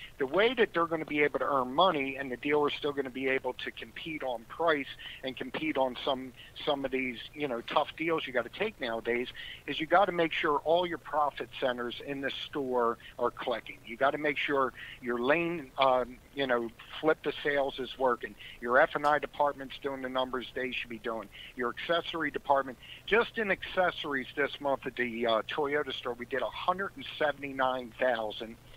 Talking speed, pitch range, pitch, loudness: 200 wpm, 125-150 Hz, 135 Hz, -31 LUFS